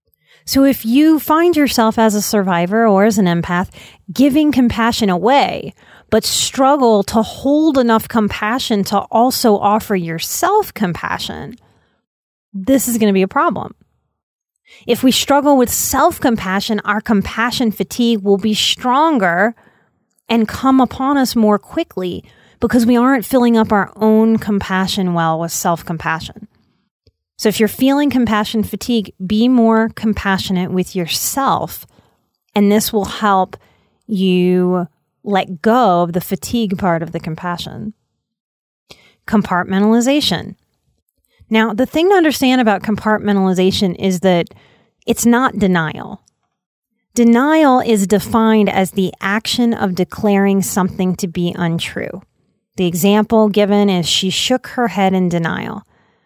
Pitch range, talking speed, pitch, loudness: 190-240 Hz, 130 wpm, 215 Hz, -15 LUFS